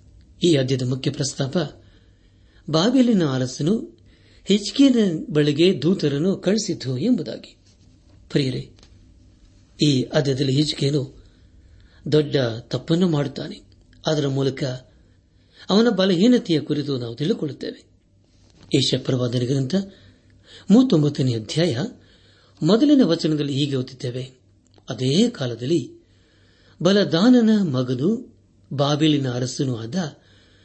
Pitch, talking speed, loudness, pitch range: 135 Hz, 75 wpm, -21 LUFS, 100-165 Hz